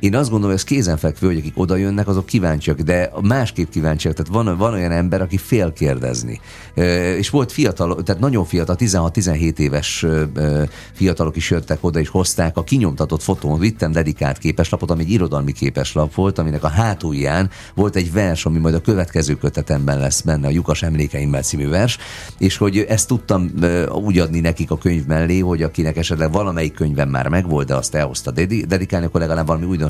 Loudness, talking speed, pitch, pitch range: -18 LUFS, 185 wpm, 85 Hz, 80-95 Hz